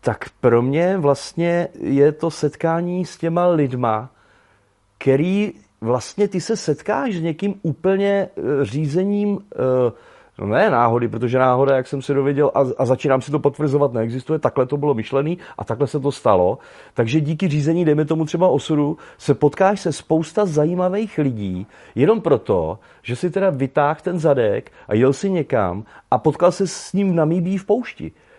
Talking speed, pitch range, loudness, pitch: 165 wpm, 135-180 Hz, -19 LUFS, 150 Hz